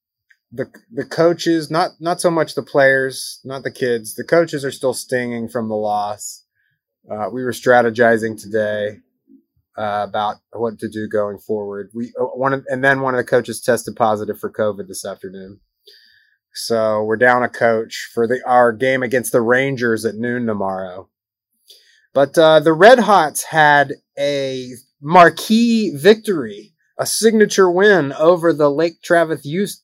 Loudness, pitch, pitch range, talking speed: -16 LUFS, 130 Hz, 115-165 Hz, 160 wpm